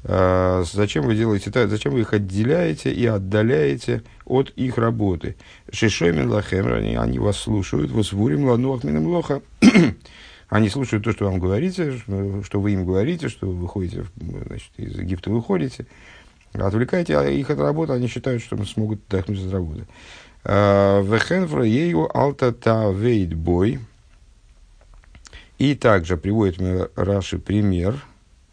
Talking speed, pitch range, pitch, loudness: 125 wpm, 90-120 Hz, 100 Hz, -21 LUFS